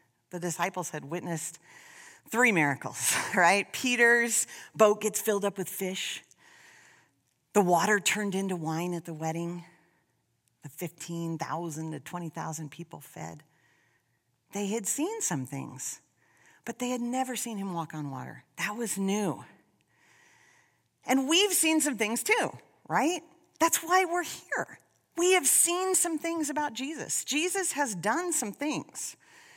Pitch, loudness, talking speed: 210 Hz, -28 LUFS, 140 wpm